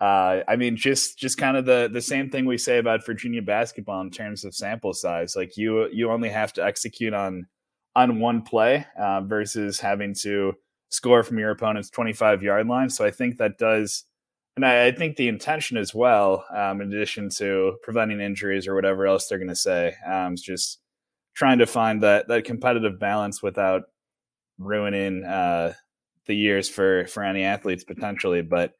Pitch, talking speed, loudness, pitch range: 105 Hz, 190 wpm, -23 LUFS, 100-120 Hz